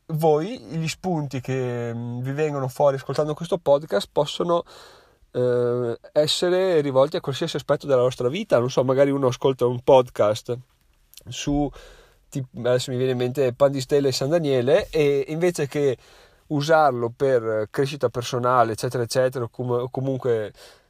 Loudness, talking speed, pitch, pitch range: -22 LUFS, 150 wpm, 135 Hz, 125-150 Hz